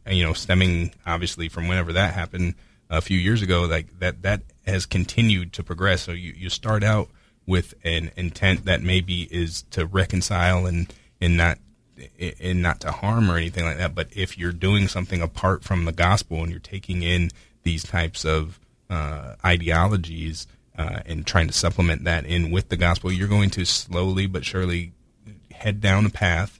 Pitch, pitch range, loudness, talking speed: 90 Hz, 85-95 Hz, -23 LUFS, 185 wpm